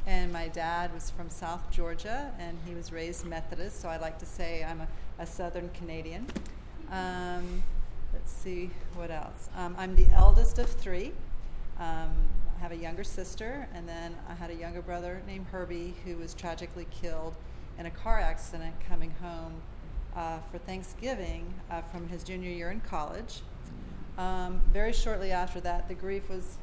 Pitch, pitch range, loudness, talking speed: 175 Hz, 165-185 Hz, -36 LUFS, 170 wpm